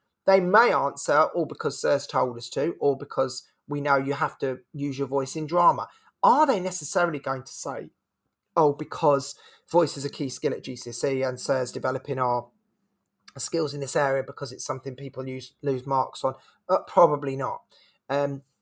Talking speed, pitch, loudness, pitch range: 175 wpm, 140 Hz, -26 LUFS, 130-150 Hz